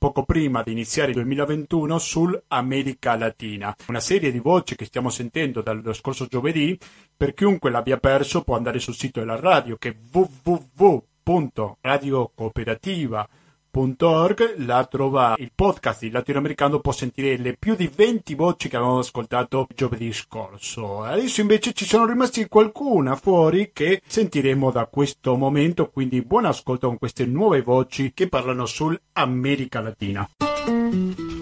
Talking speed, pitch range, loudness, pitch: 140 wpm, 125-165 Hz, -22 LUFS, 135 Hz